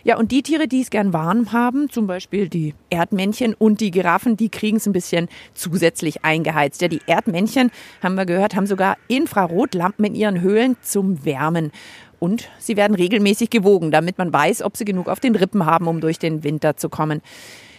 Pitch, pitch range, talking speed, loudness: 195 Hz, 165-220 Hz, 195 wpm, -19 LUFS